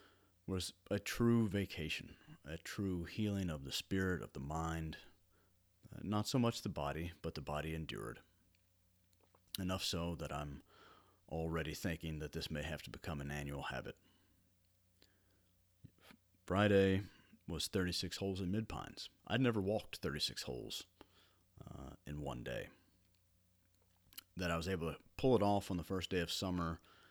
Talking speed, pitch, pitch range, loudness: 150 wpm, 90 Hz, 80-95 Hz, -40 LUFS